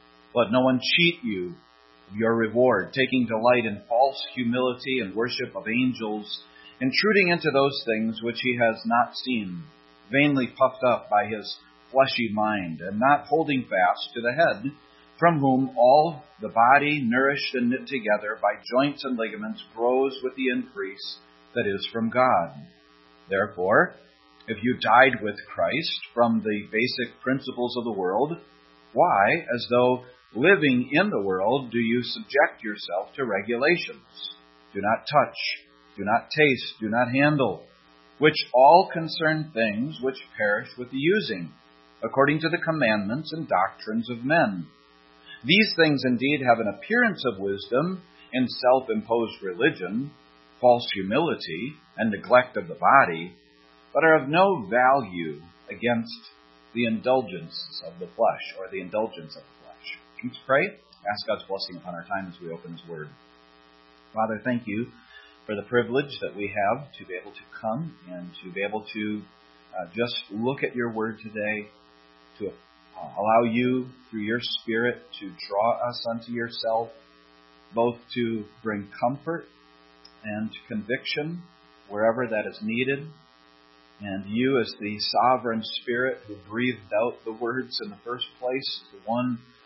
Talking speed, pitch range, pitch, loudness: 150 wpm, 85-125 Hz, 115 Hz, -24 LUFS